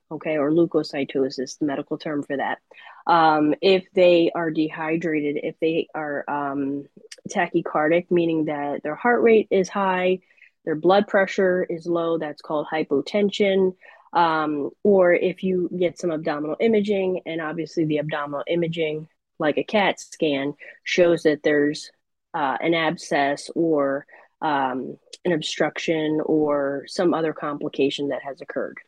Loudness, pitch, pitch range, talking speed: -22 LUFS, 160 Hz, 150-175 Hz, 140 wpm